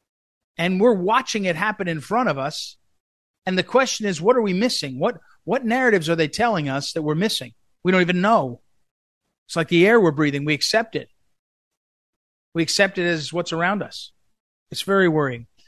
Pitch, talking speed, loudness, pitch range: 175 Hz, 190 wpm, -20 LUFS, 155-215 Hz